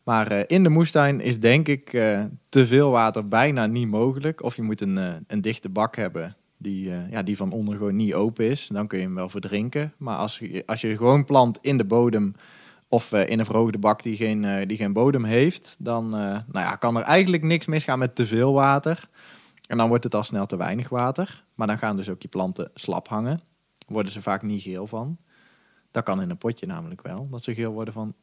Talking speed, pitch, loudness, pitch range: 225 wpm, 115 Hz, -23 LUFS, 105-135 Hz